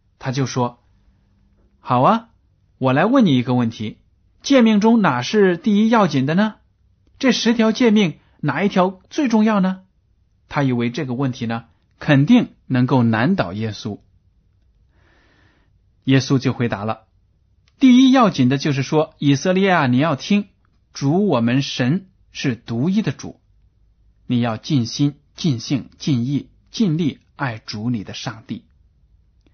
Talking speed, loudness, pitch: 200 characters per minute, -18 LUFS, 130 Hz